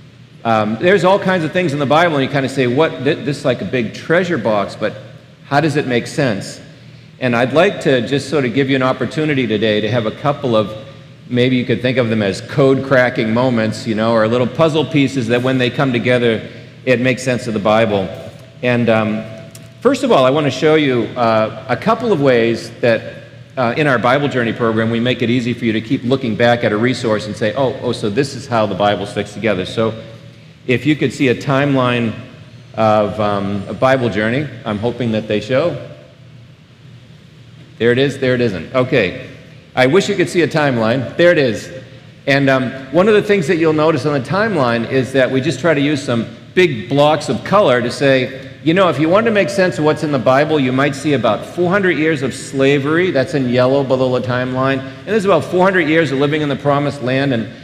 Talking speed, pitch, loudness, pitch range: 230 wpm, 130 Hz, -15 LUFS, 120-145 Hz